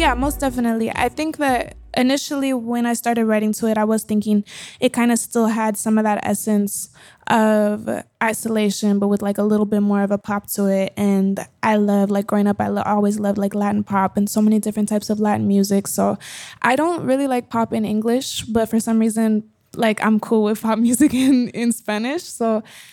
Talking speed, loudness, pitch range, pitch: 215 wpm, -19 LUFS, 205-235 Hz, 215 Hz